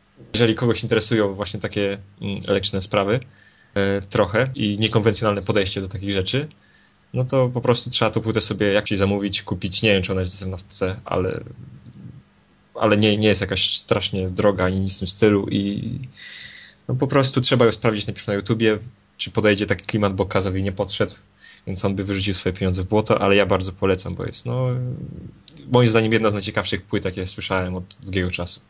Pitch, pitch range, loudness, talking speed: 105 Hz, 95-115 Hz, -20 LUFS, 185 wpm